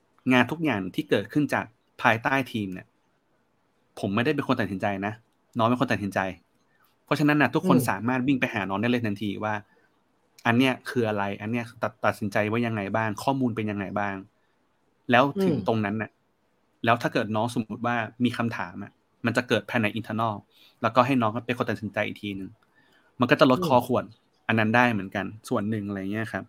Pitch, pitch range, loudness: 110 Hz, 105-125 Hz, -26 LUFS